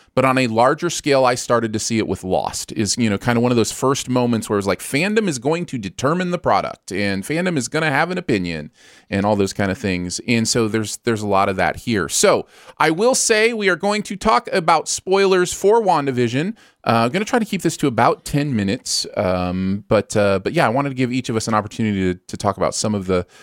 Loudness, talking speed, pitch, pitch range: -19 LUFS, 260 wpm, 120 Hz, 100-160 Hz